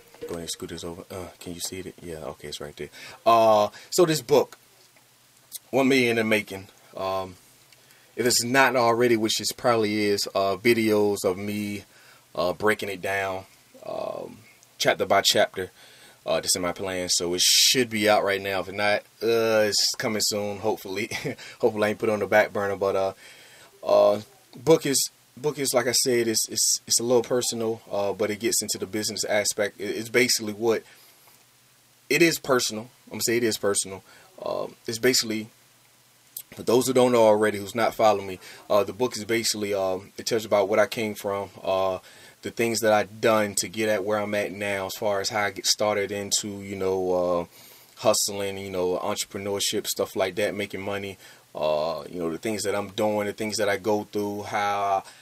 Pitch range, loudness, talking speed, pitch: 100-115 Hz, -24 LUFS, 200 wpm, 105 Hz